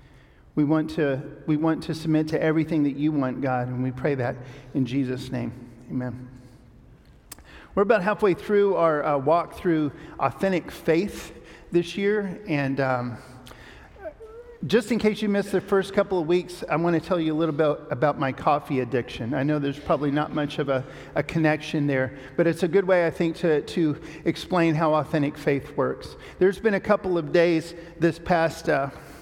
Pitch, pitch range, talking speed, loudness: 155 Hz, 135-170 Hz, 190 wpm, -24 LUFS